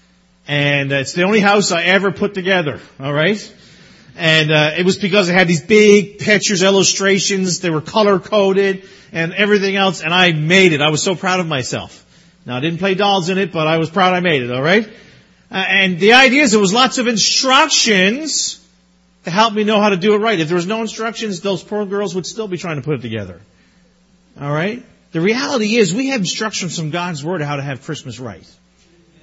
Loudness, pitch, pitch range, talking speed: -14 LUFS, 190 Hz, 160-210 Hz, 220 wpm